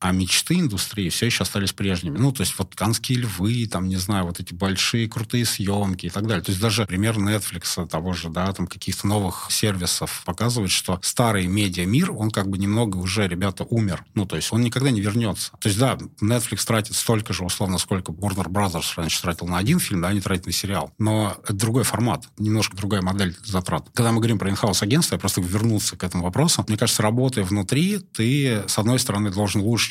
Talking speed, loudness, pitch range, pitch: 215 wpm, -22 LUFS, 95-115 Hz, 100 Hz